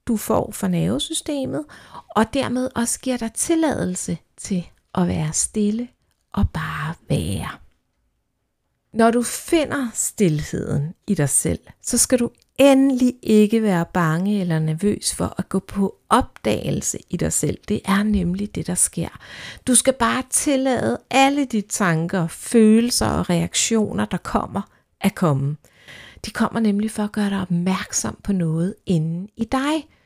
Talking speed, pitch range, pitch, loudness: 150 wpm, 180-245 Hz, 210 Hz, -21 LUFS